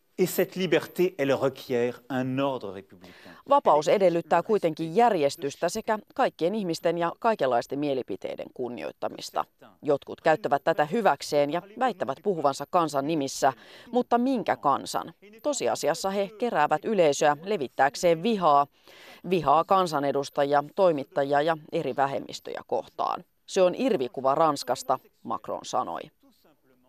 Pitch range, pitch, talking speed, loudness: 140-200 Hz, 165 Hz, 95 wpm, -26 LUFS